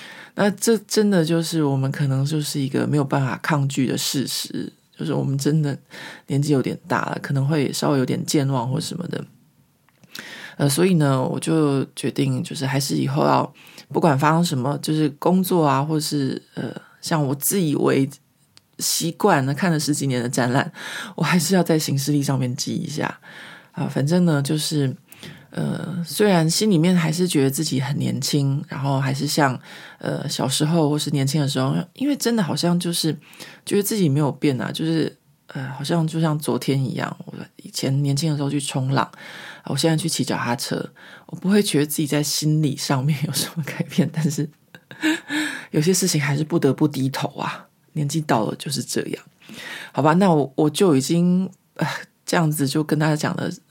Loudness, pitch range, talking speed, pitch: -21 LUFS, 140-170 Hz, 275 characters per minute, 150 Hz